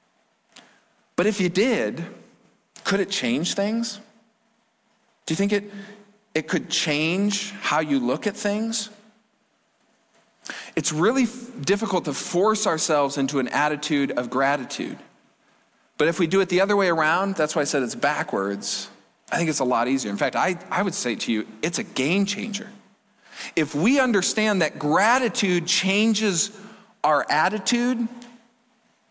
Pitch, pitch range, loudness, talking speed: 200 Hz, 155-220 Hz, -23 LUFS, 150 wpm